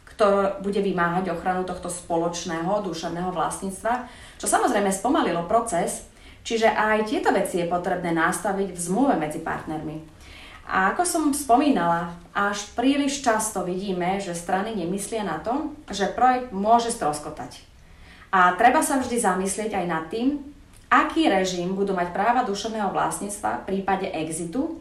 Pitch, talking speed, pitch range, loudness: 195 Hz, 140 wpm, 175-230 Hz, -24 LUFS